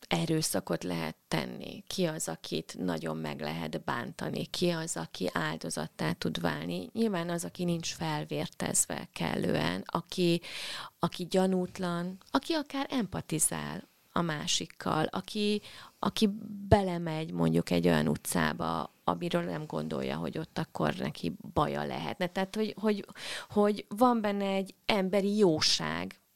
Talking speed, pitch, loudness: 125 wpm, 170 Hz, -32 LUFS